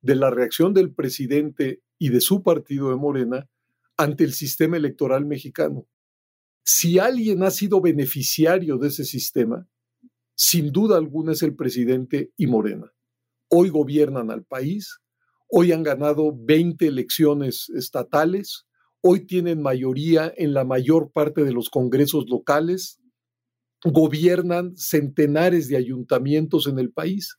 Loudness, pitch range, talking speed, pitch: -21 LUFS, 130-170 Hz, 130 wpm, 150 Hz